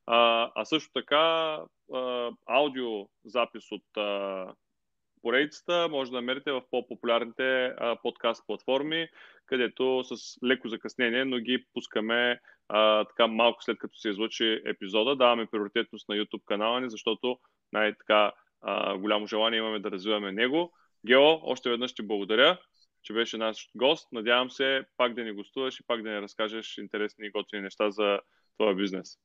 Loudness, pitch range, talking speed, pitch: -28 LUFS, 105-125 Hz, 140 wpm, 115 Hz